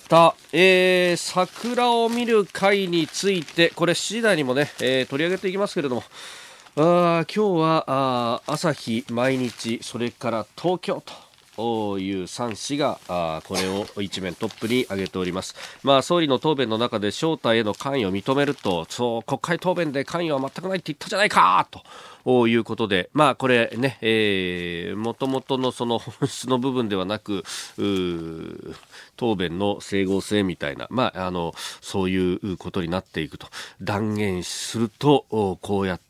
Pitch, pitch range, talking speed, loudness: 125 Hz, 100-160 Hz, 305 characters per minute, -23 LUFS